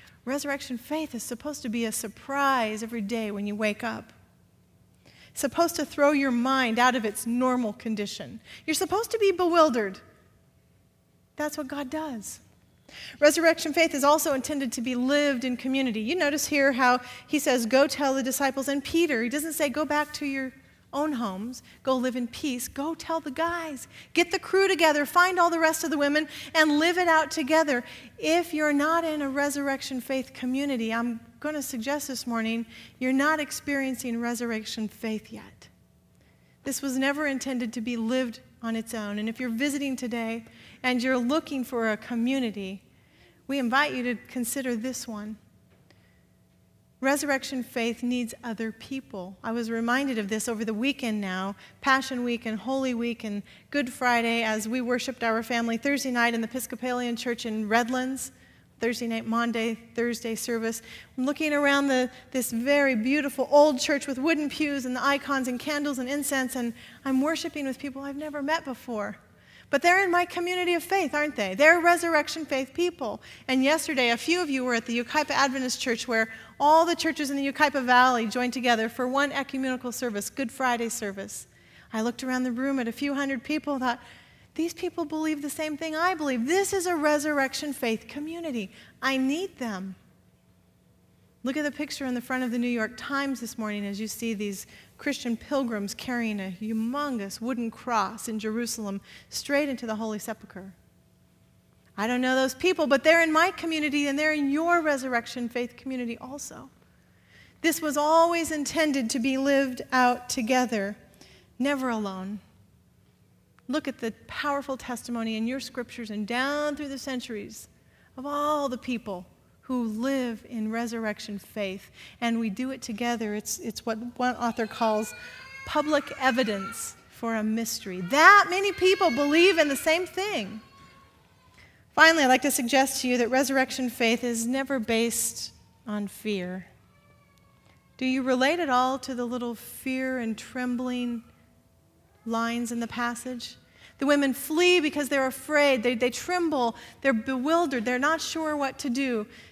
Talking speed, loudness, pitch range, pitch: 175 wpm, -26 LUFS, 235-290 Hz, 260 Hz